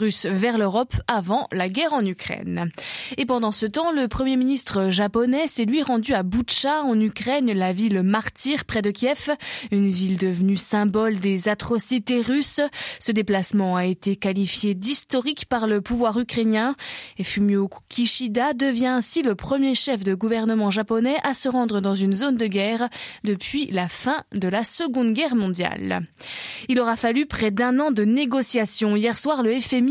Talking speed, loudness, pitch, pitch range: 170 wpm, -22 LUFS, 230 Hz, 205-260 Hz